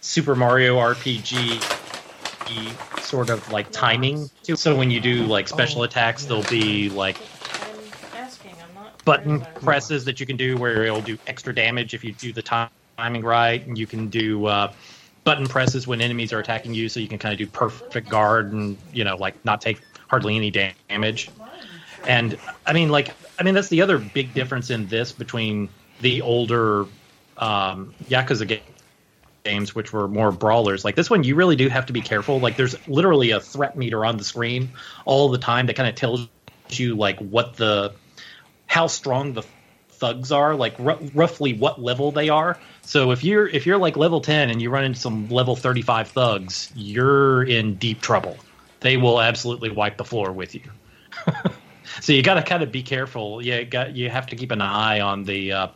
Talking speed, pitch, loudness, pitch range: 190 wpm, 120 Hz, -21 LUFS, 110-135 Hz